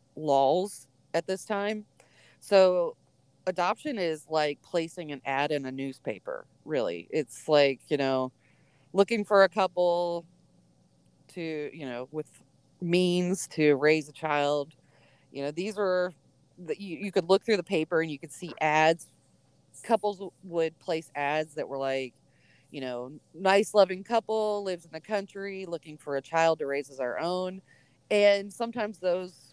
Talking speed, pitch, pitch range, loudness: 155 wpm, 165 Hz, 140-190 Hz, -28 LUFS